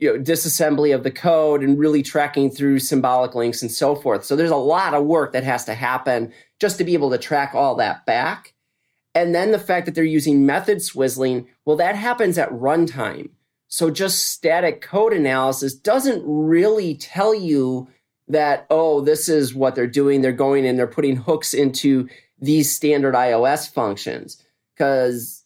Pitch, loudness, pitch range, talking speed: 145 Hz, -19 LUFS, 130-165 Hz, 180 wpm